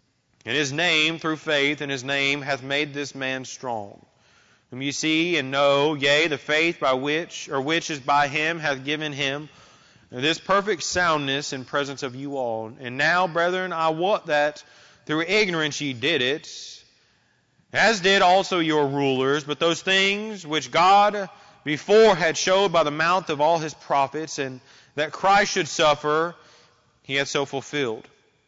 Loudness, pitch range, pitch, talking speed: -22 LUFS, 140-165 Hz, 150 Hz, 165 wpm